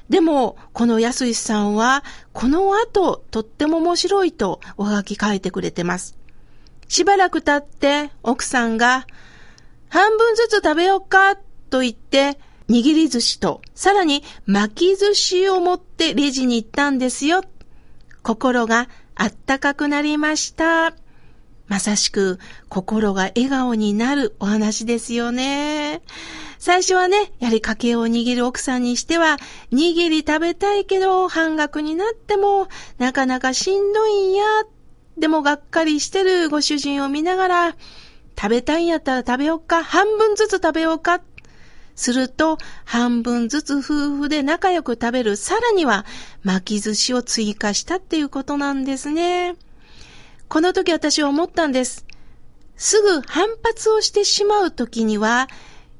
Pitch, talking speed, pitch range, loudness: 295 Hz, 275 characters per minute, 240-360 Hz, -19 LUFS